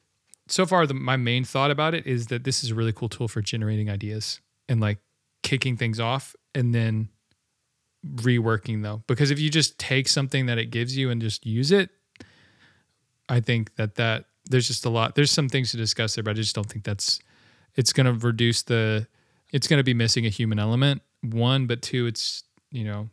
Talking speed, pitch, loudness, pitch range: 210 wpm, 120 Hz, -24 LUFS, 110-130 Hz